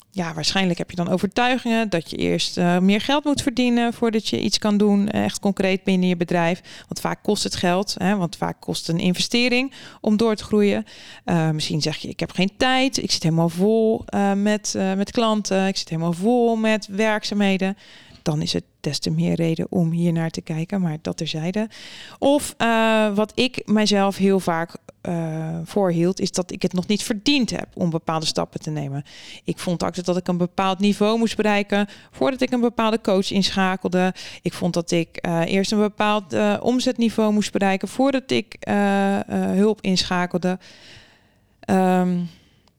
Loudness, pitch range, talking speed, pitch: -21 LUFS, 175-215 Hz, 190 wpm, 195 Hz